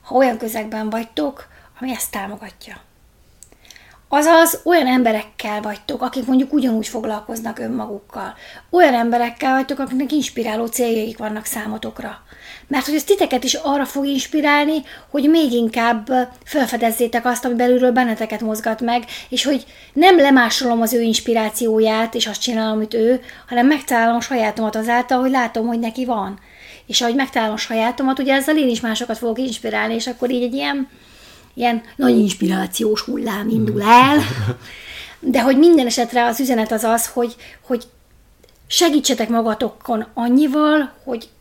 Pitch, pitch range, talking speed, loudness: 240 Hz, 225-270 Hz, 145 wpm, -17 LUFS